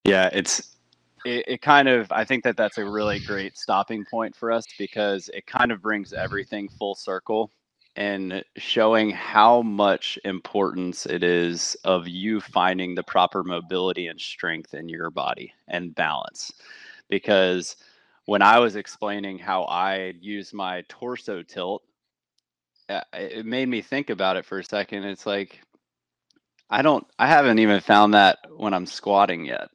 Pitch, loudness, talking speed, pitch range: 100 Hz, -23 LUFS, 155 wpm, 90-110 Hz